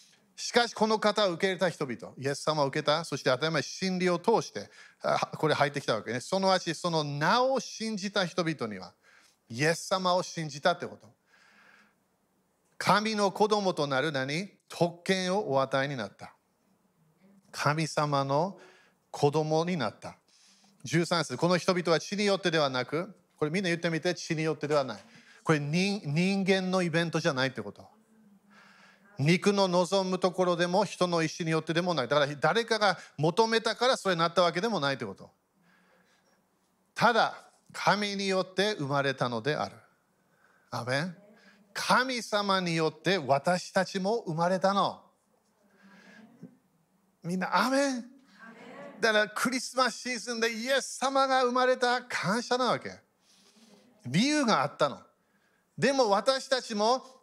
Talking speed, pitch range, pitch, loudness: 290 characters per minute, 160-210 Hz, 185 Hz, -28 LUFS